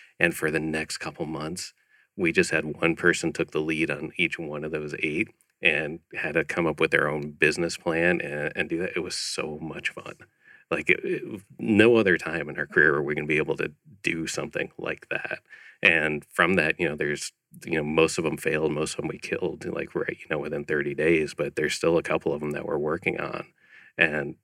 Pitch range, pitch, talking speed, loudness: 75-85 Hz, 80 Hz, 235 wpm, -26 LUFS